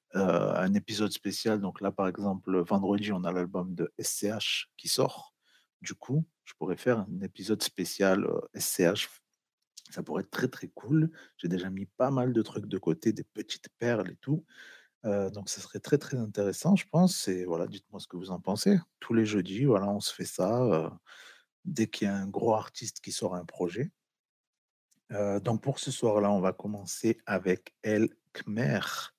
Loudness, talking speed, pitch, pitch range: -31 LUFS, 195 wpm, 100 Hz, 95-120 Hz